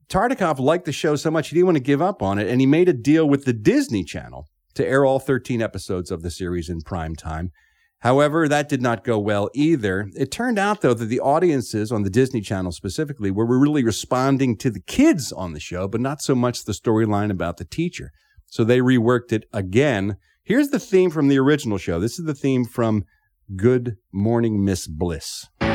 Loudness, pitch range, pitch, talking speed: -21 LUFS, 100-145 Hz, 120 Hz, 215 wpm